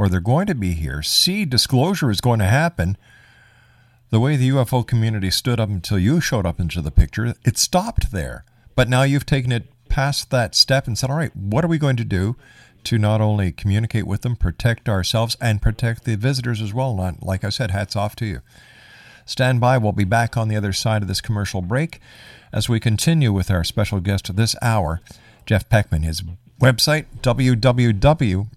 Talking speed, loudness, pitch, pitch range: 200 wpm, -19 LUFS, 115 Hz, 100-125 Hz